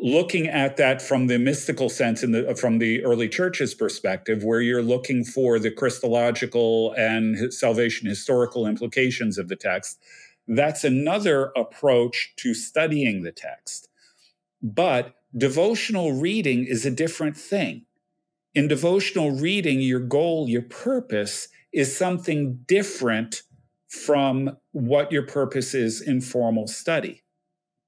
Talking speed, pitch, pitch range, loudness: 125 wpm, 130 Hz, 120-150 Hz, -23 LUFS